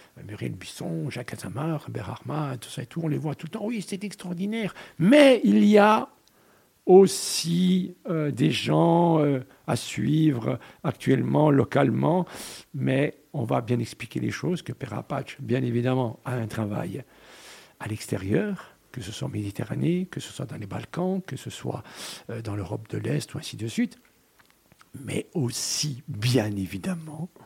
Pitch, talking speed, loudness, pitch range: 145 Hz, 165 wpm, -25 LUFS, 120-175 Hz